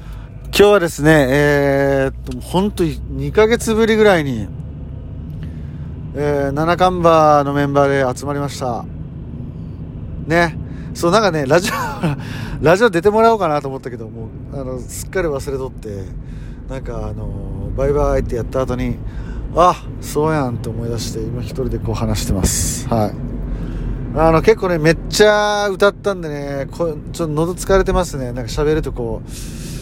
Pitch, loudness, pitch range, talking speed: 140 Hz, -17 LUFS, 125-165 Hz, 320 characters per minute